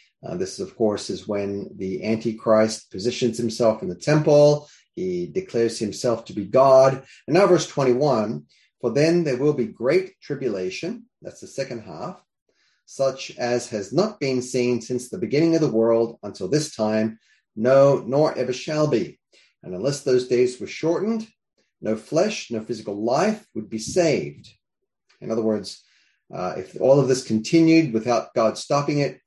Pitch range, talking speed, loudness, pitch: 110-150 Hz, 170 wpm, -22 LUFS, 125 Hz